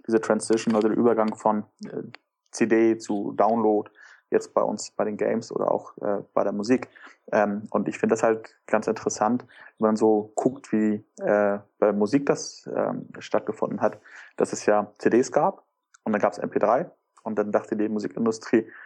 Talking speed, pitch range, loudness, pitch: 180 wpm, 105-115 Hz, -25 LUFS, 110 Hz